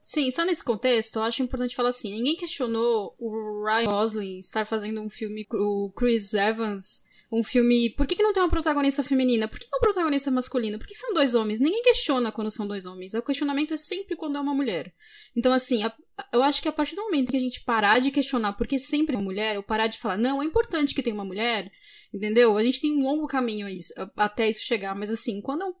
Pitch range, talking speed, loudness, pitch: 220-285 Hz, 240 wpm, -24 LUFS, 245 Hz